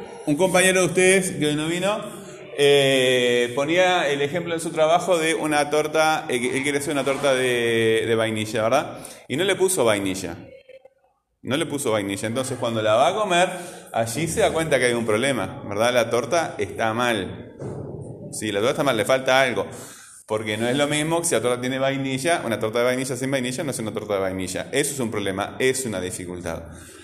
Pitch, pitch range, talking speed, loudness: 135 Hz, 115-160 Hz, 205 wpm, -22 LUFS